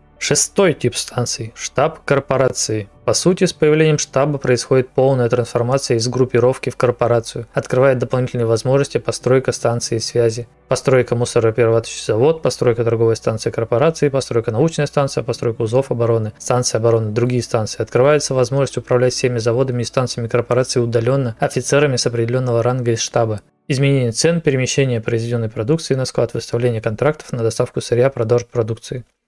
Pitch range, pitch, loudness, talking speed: 115-135 Hz, 125 Hz, -17 LUFS, 140 wpm